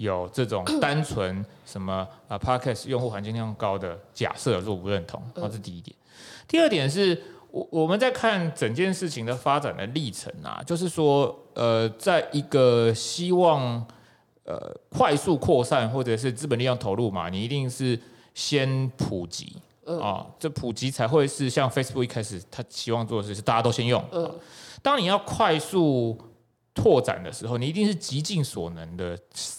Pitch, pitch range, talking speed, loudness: 125 Hz, 115-155 Hz, 280 characters per minute, -26 LUFS